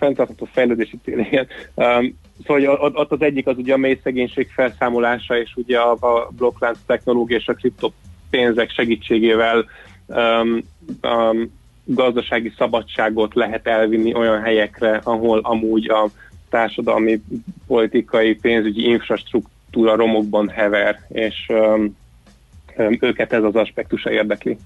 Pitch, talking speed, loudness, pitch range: 115 Hz, 120 wpm, -18 LUFS, 110-120 Hz